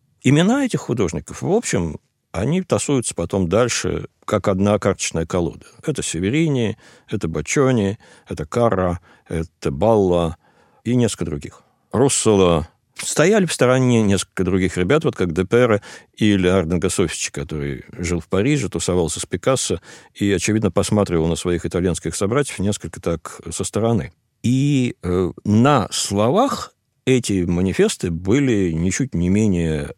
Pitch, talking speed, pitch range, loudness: 100 Hz, 130 wpm, 90-120 Hz, -19 LUFS